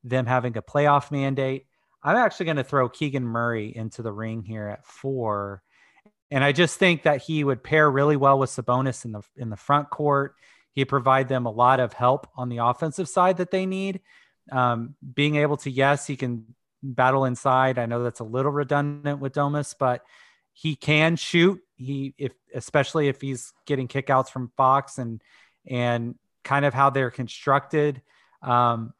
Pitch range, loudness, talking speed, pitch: 125-145 Hz, -24 LUFS, 180 wpm, 135 Hz